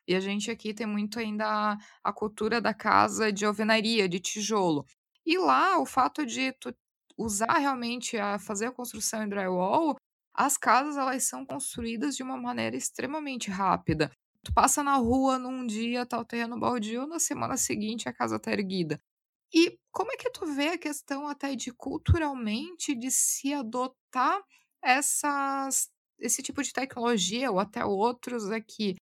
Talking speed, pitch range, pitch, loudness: 165 wpm, 215-275 Hz, 245 Hz, -29 LUFS